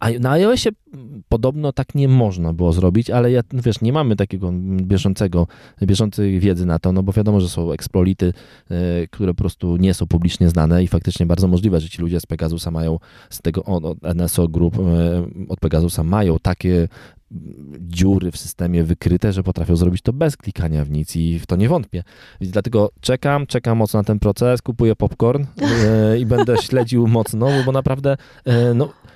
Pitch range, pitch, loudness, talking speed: 85-120 Hz, 95 Hz, -18 LUFS, 175 wpm